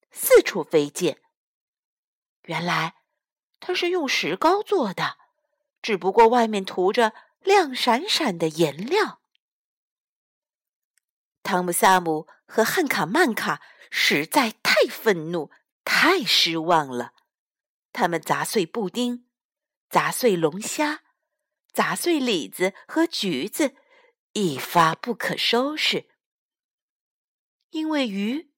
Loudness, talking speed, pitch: -22 LUFS, 145 characters per minute, 245 Hz